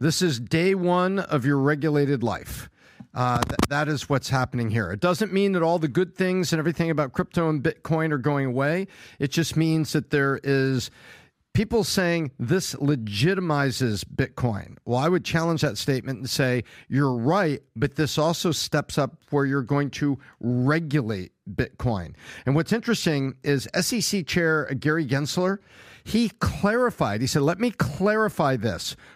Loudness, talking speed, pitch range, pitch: -24 LUFS, 165 wpm, 130-170 Hz, 150 Hz